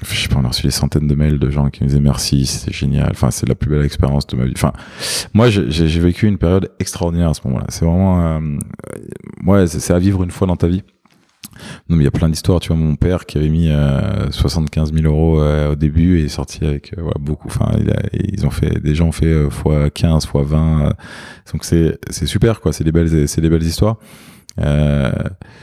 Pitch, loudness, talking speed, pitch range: 80 Hz, -16 LUFS, 255 wpm, 75-90 Hz